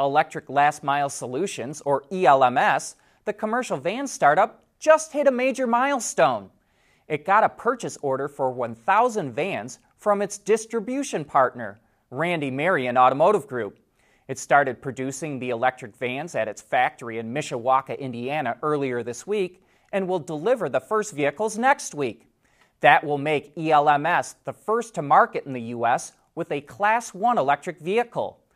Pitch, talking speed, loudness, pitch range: 155 Hz, 150 wpm, -23 LUFS, 135-210 Hz